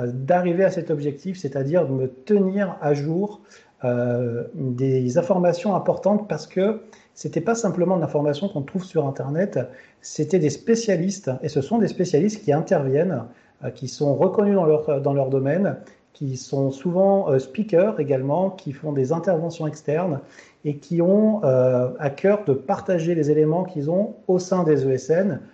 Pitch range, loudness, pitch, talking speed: 140-190 Hz, -22 LUFS, 160 Hz, 165 wpm